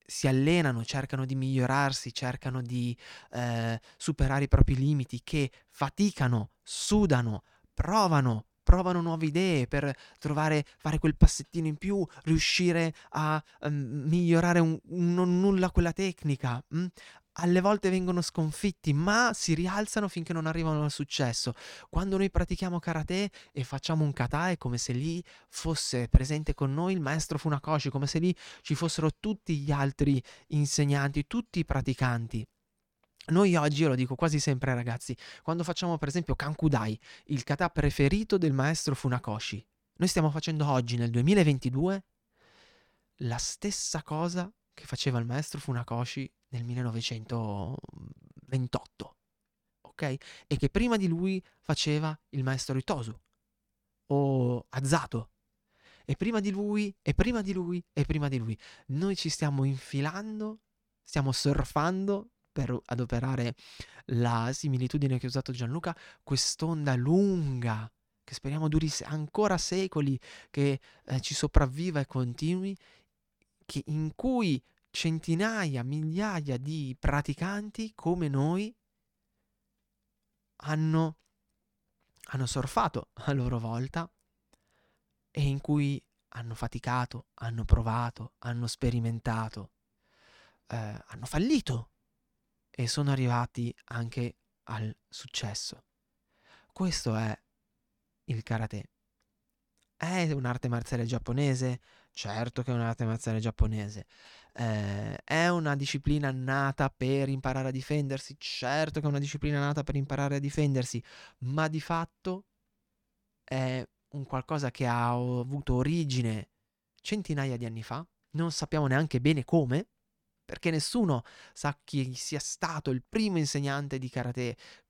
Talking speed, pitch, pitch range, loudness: 125 wpm, 145 Hz, 125-165 Hz, -30 LUFS